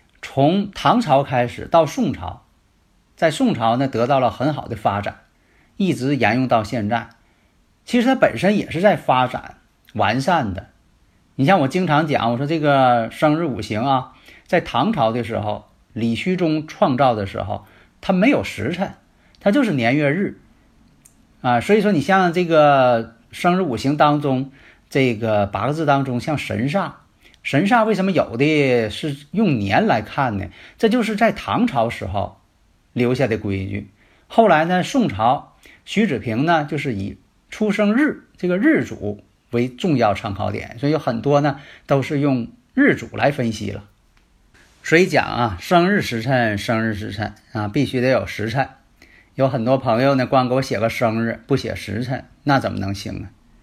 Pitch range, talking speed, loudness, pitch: 110-150 Hz, 235 characters per minute, -19 LUFS, 125 Hz